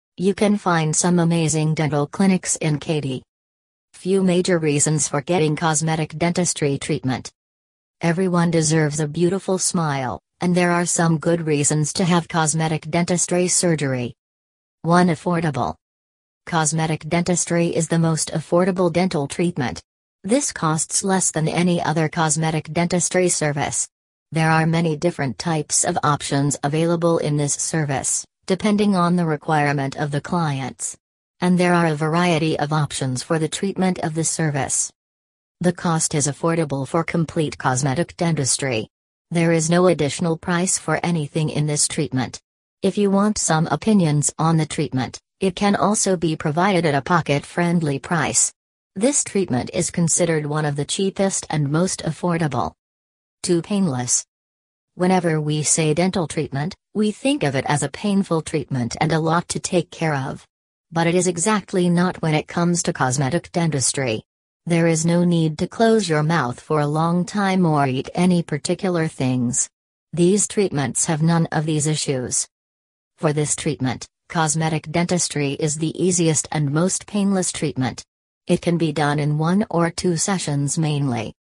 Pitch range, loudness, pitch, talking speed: 145-175 Hz, -20 LUFS, 160 Hz, 155 wpm